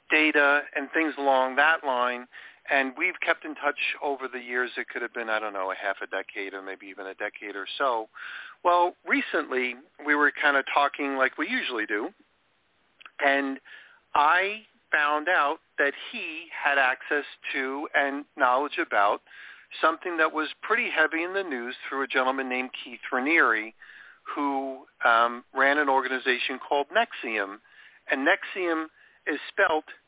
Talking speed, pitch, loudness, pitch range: 160 wpm, 140 Hz, -26 LUFS, 125-155 Hz